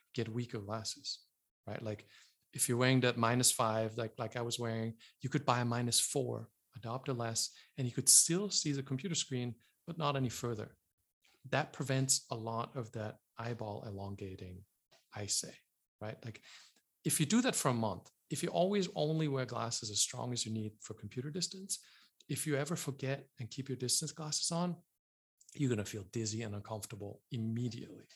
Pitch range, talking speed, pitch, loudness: 110-140 Hz, 190 wpm, 120 Hz, -35 LUFS